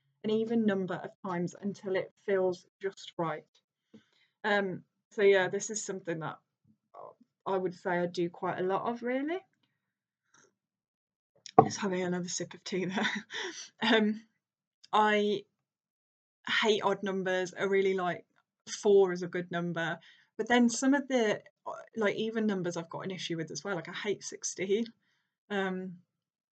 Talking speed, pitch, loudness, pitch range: 150 wpm, 195 Hz, -32 LUFS, 180-215 Hz